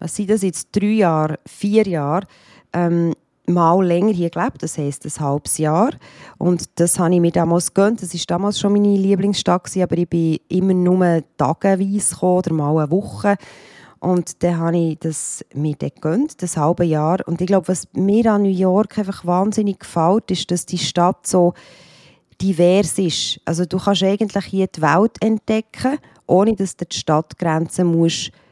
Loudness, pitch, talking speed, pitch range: -18 LUFS, 180 Hz, 175 wpm, 165-195 Hz